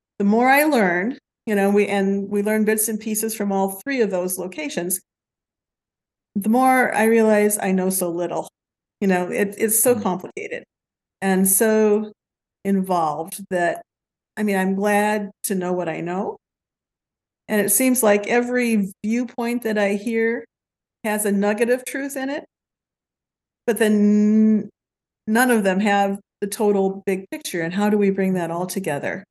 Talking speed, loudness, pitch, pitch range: 165 wpm, -20 LUFS, 210 Hz, 195-225 Hz